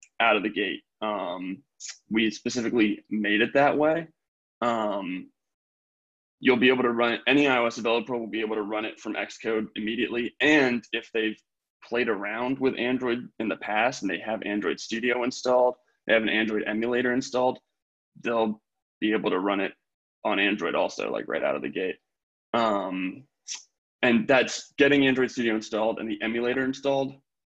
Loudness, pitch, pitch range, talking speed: -26 LUFS, 120 Hz, 110-130 Hz, 170 wpm